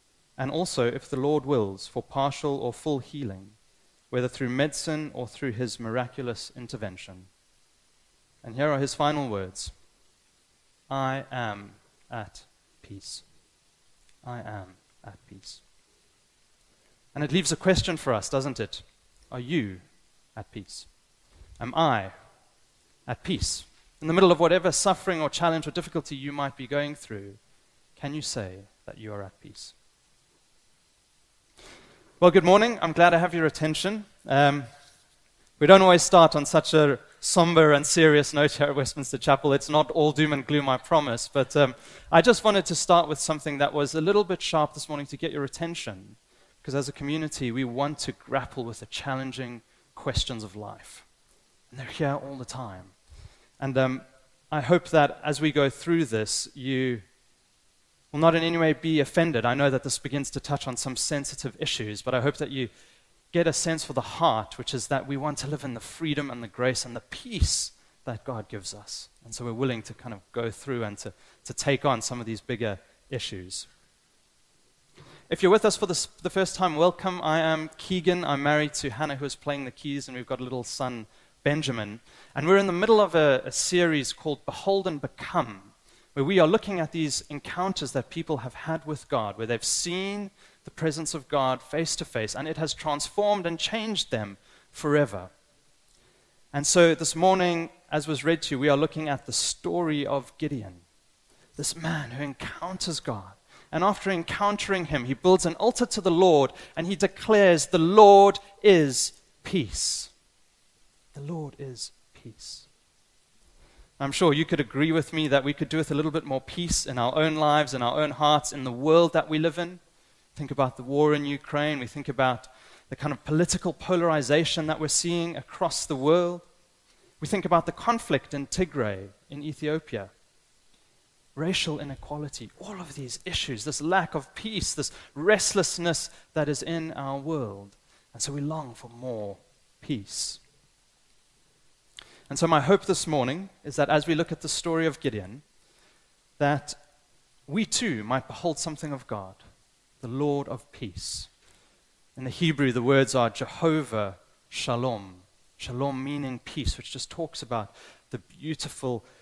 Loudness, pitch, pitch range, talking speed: -26 LUFS, 145 Hz, 125-165 Hz, 180 wpm